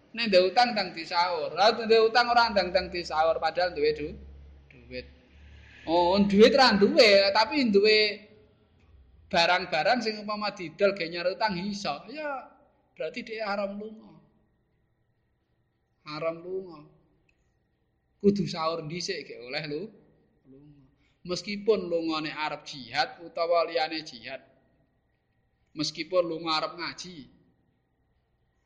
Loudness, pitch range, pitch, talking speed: -26 LUFS, 155-205 Hz, 180 Hz, 110 wpm